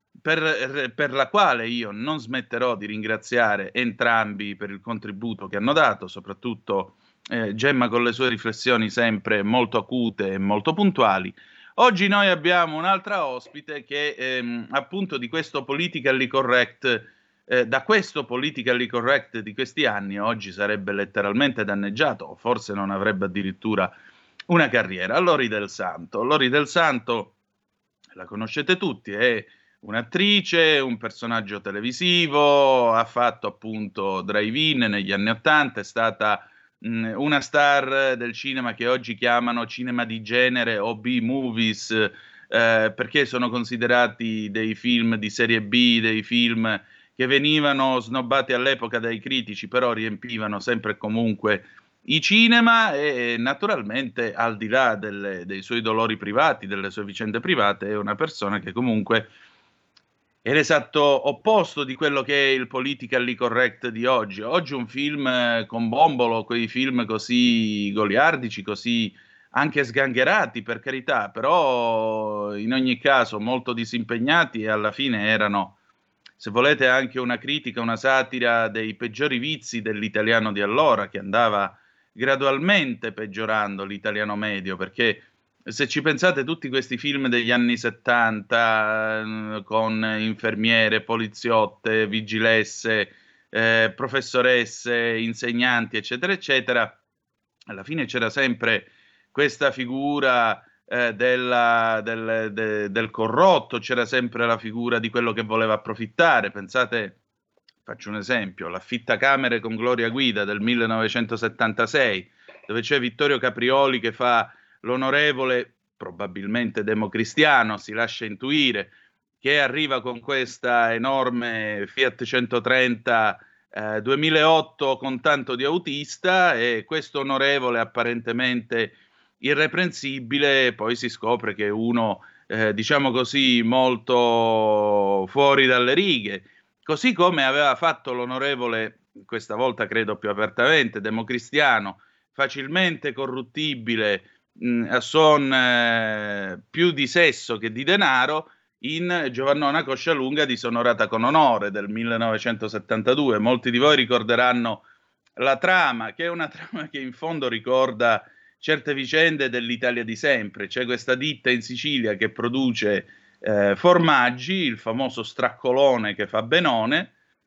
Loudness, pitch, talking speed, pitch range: -22 LUFS, 120 Hz, 125 wpm, 110-135 Hz